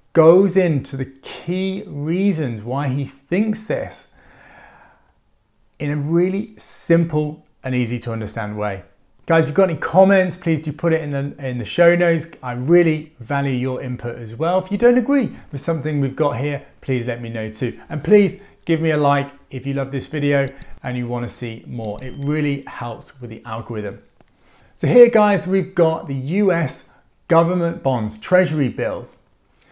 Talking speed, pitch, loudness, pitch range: 180 wpm, 145 Hz, -19 LUFS, 125-170 Hz